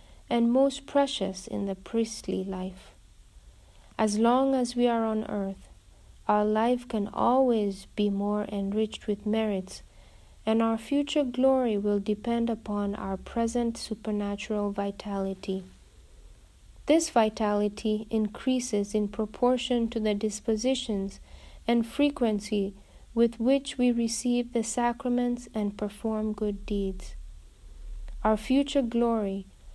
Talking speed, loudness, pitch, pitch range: 115 wpm, -28 LUFS, 220 Hz, 205-240 Hz